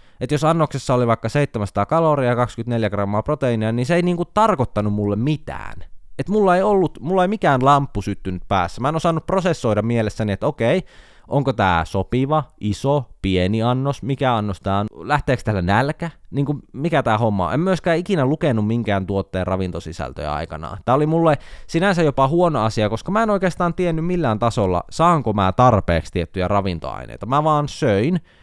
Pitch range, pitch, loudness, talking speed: 100-155 Hz, 125 Hz, -20 LUFS, 175 wpm